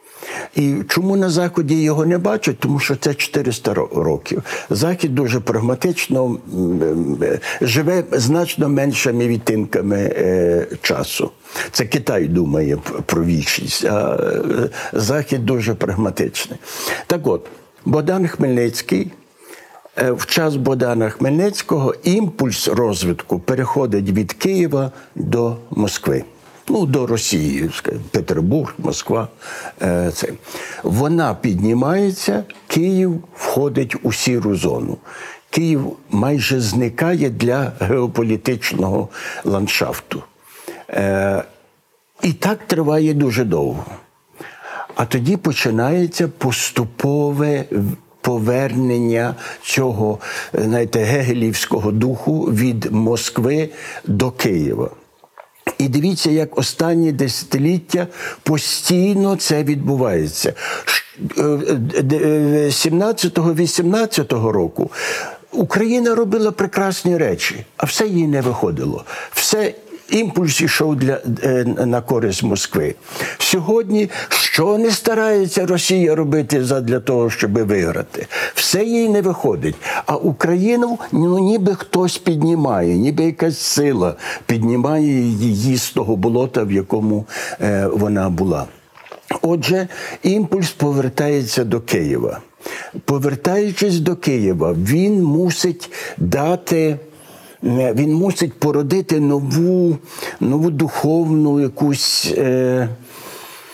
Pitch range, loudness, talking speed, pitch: 120-175 Hz, -18 LUFS, 90 wpm, 145 Hz